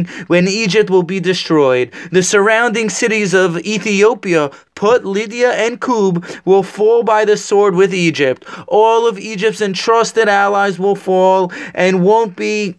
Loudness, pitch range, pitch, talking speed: -13 LUFS, 185-220 Hz, 200 Hz, 145 wpm